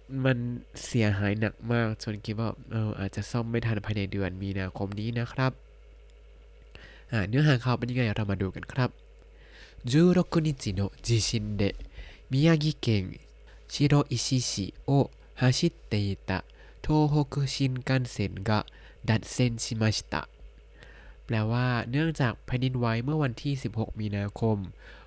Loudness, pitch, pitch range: -28 LUFS, 115 Hz, 105-135 Hz